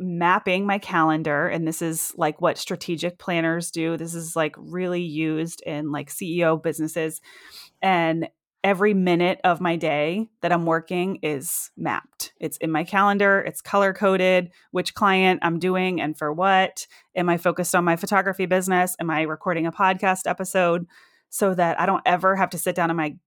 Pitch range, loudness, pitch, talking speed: 165-185 Hz, -23 LUFS, 175 Hz, 180 wpm